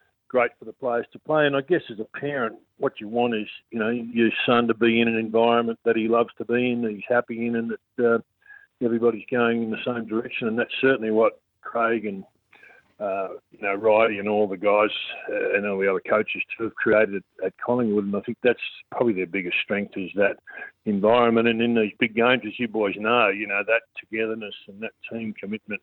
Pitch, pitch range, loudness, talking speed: 115 Hz, 105-120 Hz, -24 LUFS, 225 wpm